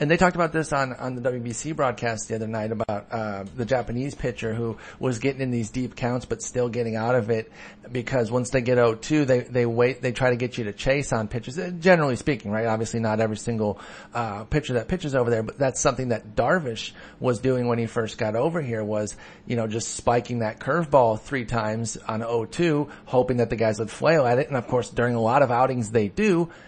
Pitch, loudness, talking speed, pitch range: 120 Hz, -25 LUFS, 240 wpm, 115-130 Hz